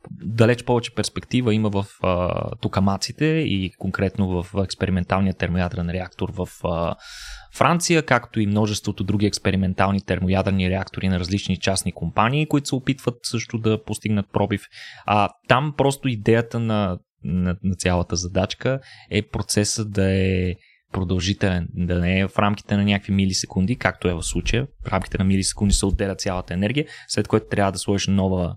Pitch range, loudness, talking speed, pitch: 95-110 Hz, -22 LUFS, 155 wpm, 100 Hz